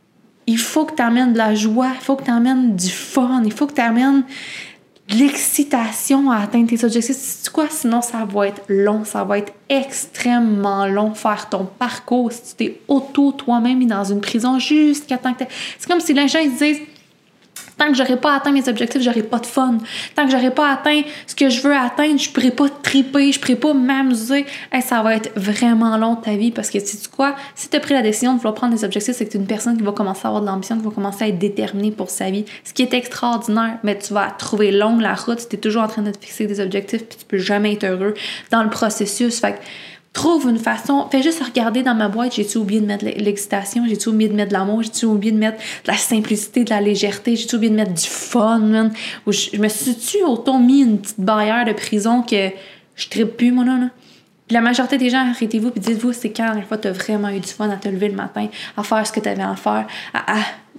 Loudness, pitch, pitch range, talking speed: -18 LUFS, 230 Hz, 210-260 Hz, 260 wpm